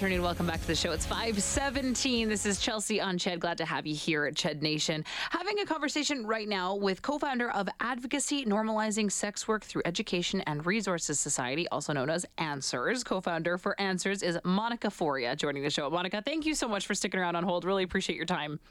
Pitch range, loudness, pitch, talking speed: 170-225 Hz, -31 LUFS, 195 Hz, 205 wpm